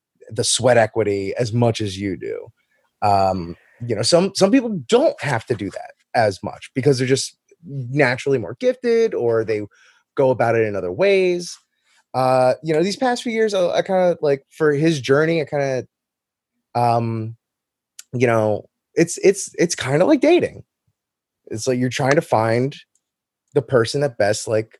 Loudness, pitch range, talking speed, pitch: -19 LUFS, 115-180 Hz, 180 wpm, 135 Hz